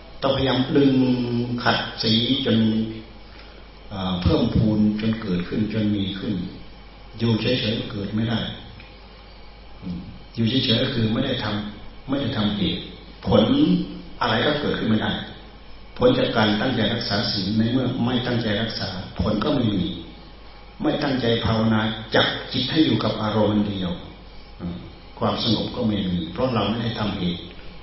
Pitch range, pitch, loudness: 100-115 Hz, 110 Hz, -22 LUFS